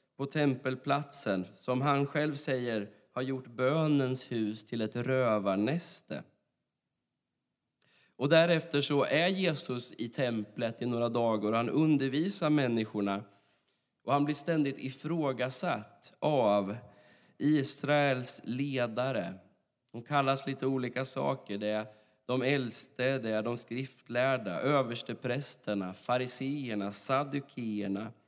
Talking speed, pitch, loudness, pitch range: 110 wpm, 130 Hz, -32 LUFS, 110-140 Hz